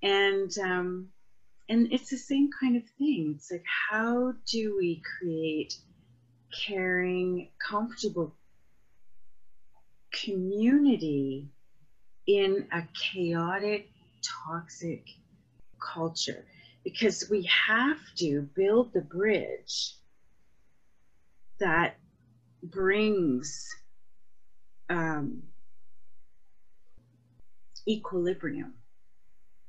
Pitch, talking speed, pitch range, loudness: 175 Hz, 70 wpm, 130-205 Hz, -29 LUFS